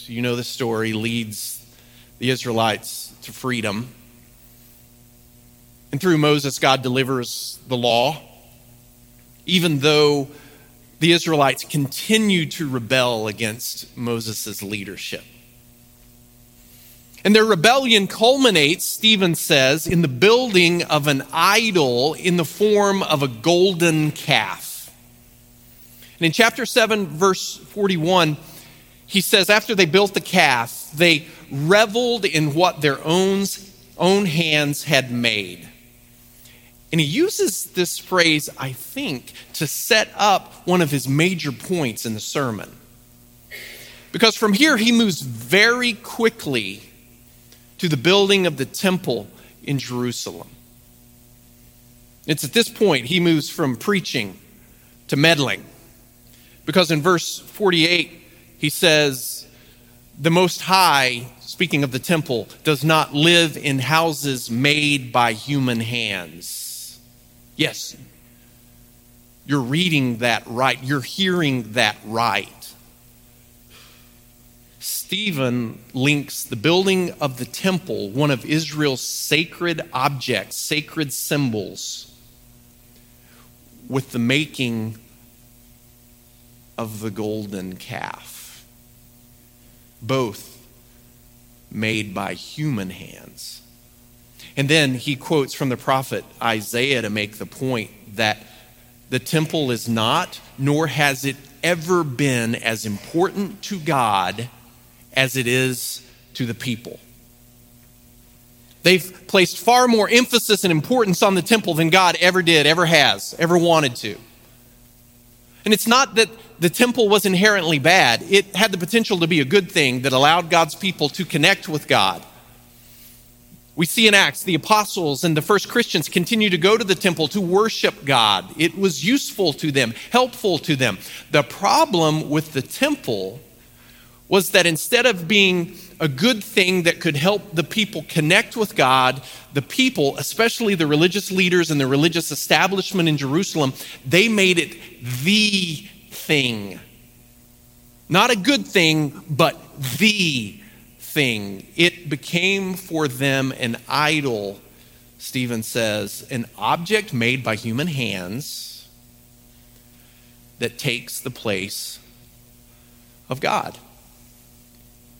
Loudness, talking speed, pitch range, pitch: -19 LUFS, 120 wpm, 120-175 Hz, 135 Hz